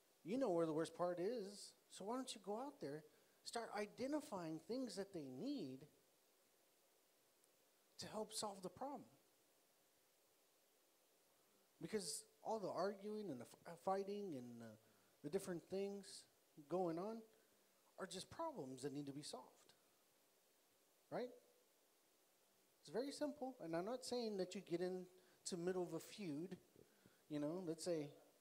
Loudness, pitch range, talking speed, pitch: -49 LUFS, 165-225 Hz, 145 wpm, 190 Hz